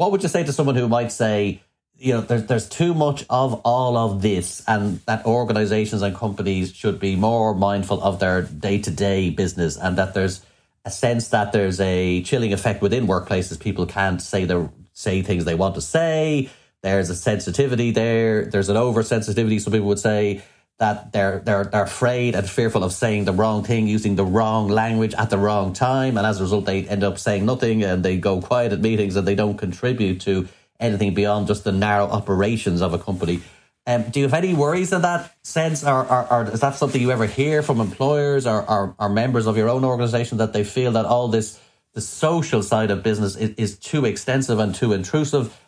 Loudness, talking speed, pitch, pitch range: -21 LUFS, 210 wpm, 110 Hz, 100-120 Hz